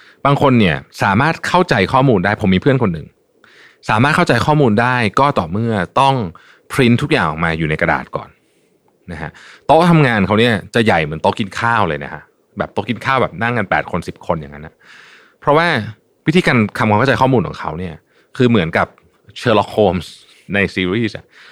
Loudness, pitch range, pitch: -15 LUFS, 95-135 Hz, 115 Hz